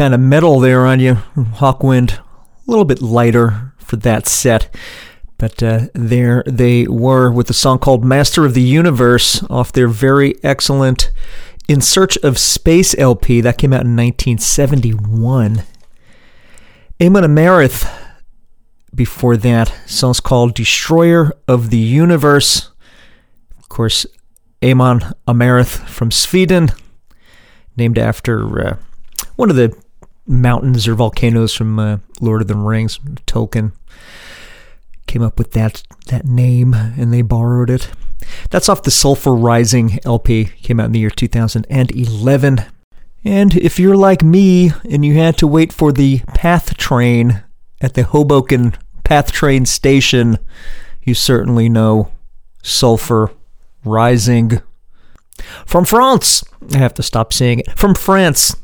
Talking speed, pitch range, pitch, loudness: 135 wpm, 115-140 Hz, 125 Hz, -12 LUFS